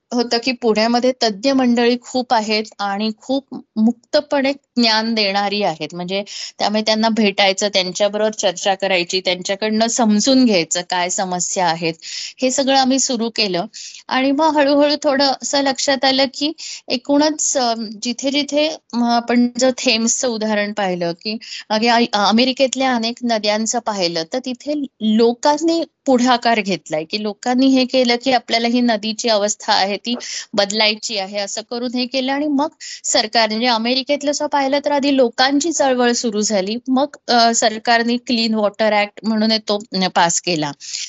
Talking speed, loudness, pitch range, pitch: 140 wpm, -17 LUFS, 210-265 Hz, 235 Hz